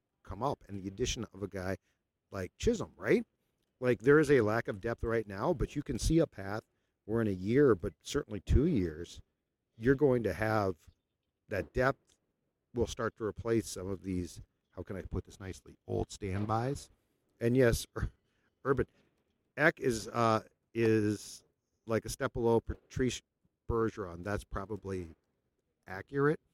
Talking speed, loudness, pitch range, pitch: 160 wpm, -33 LUFS, 95-115 Hz, 105 Hz